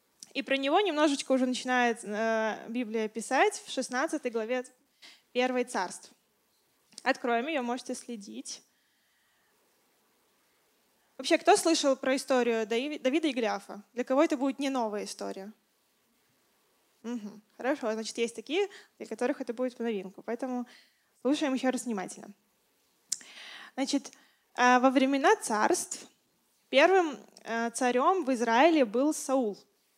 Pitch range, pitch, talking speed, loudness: 230-280 Hz, 255 Hz, 115 wpm, -29 LUFS